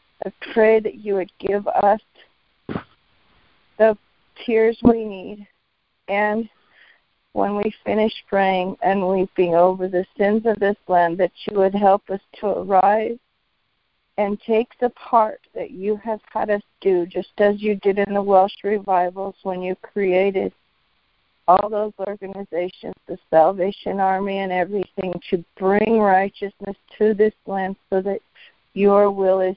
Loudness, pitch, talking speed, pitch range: -20 LUFS, 200 Hz, 145 wpm, 190-210 Hz